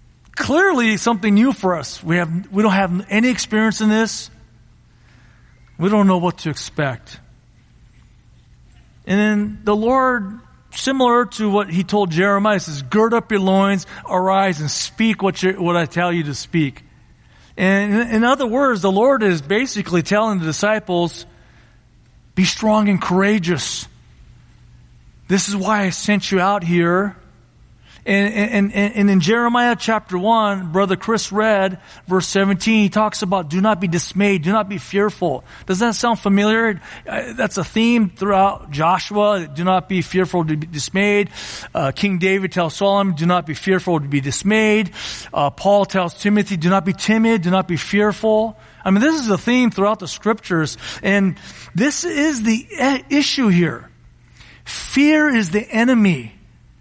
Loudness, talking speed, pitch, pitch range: -17 LUFS, 160 wpm, 195 Hz, 175-215 Hz